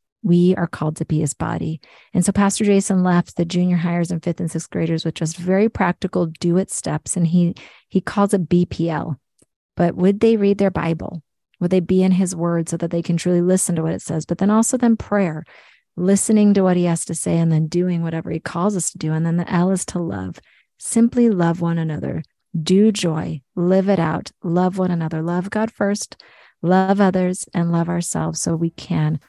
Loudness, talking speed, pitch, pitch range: -19 LUFS, 215 wpm, 175 Hz, 165-190 Hz